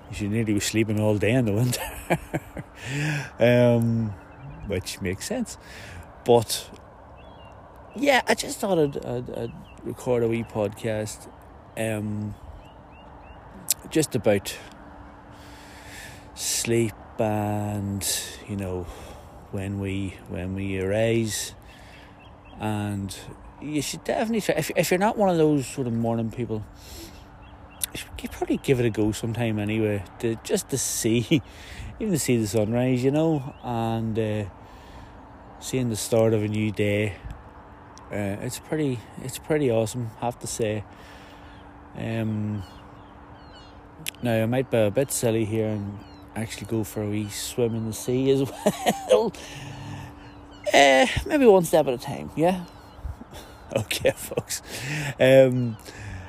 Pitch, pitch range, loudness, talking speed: 105 Hz, 95-125 Hz, -25 LUFS, 135 wpm